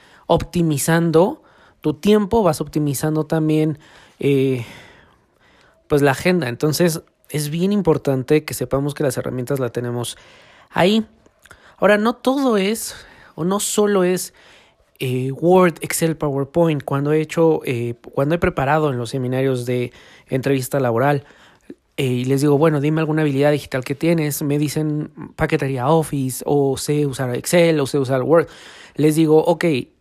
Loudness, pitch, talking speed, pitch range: -19 LUFS, 150 Hz, 145 wpm, 135-165 Hz